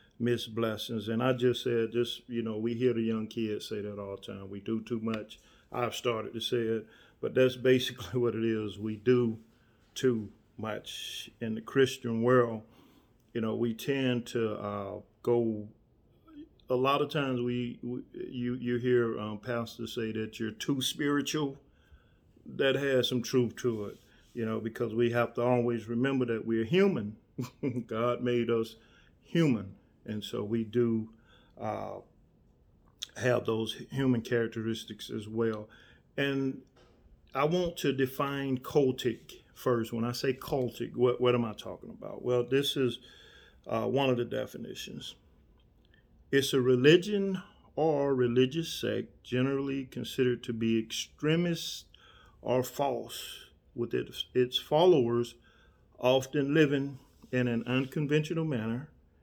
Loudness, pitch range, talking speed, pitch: -31 LUFS, 115-130 Hz, 145 wpm, 120 Hz